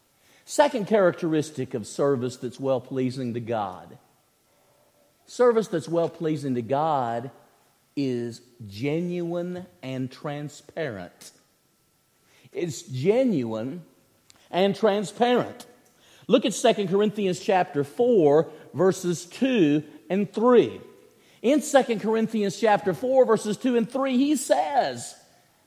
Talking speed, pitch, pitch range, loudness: 105 wpm, 175 Hz, 135-220 Hz, -24 LUFS